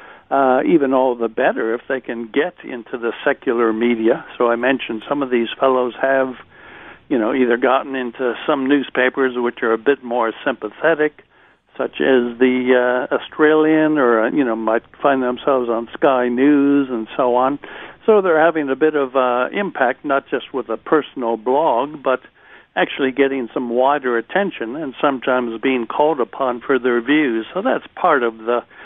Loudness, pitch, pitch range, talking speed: -18 LUFS, 130 Hz, 120-140 Hz, 175 wpm